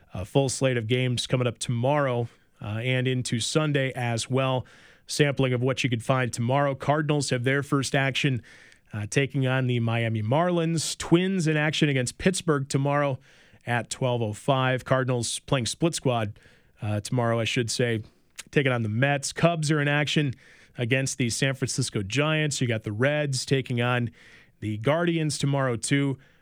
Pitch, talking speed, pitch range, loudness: 130 Hz, 165 wpm, 120-145 Hz, -25 LUFS